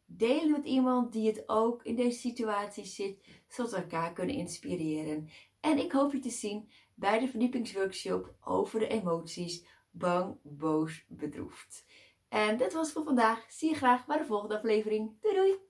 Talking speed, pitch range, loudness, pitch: 170 wpm, 180-250 Hz, -32 LUFS, 220 Hz